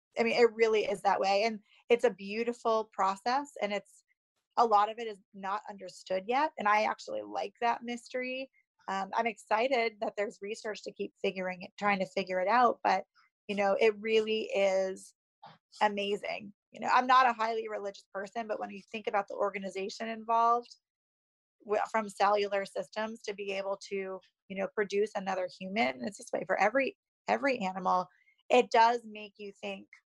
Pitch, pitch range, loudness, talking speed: 210 Hz, 195-230 Hz, -31 LUFS, 180 wpm